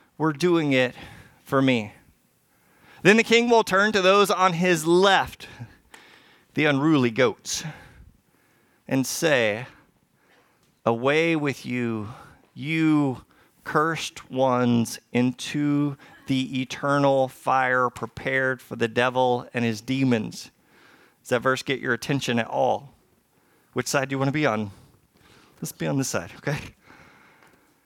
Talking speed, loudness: 125 wpm, -23 LUFS